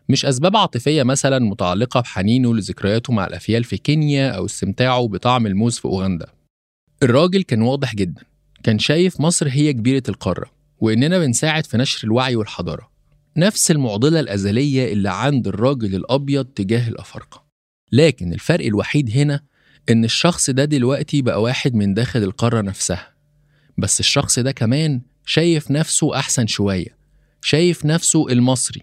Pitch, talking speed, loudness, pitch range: 130 Hz, 140 wpm, -18 LUFS, 110-145 Hz